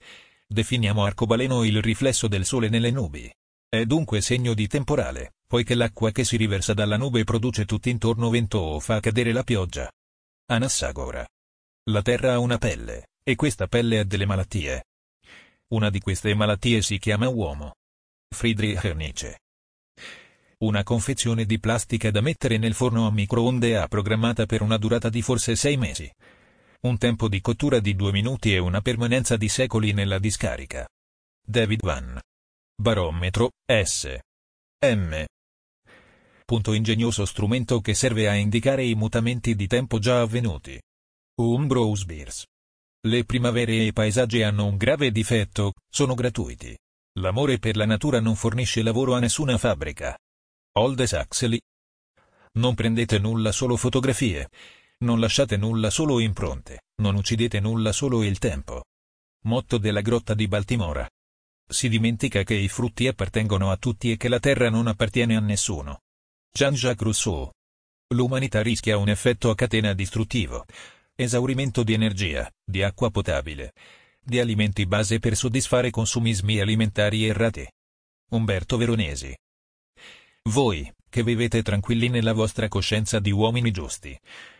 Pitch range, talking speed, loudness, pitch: 100-120 Hz, 140 wpm, -24 LUFS, 110 Hz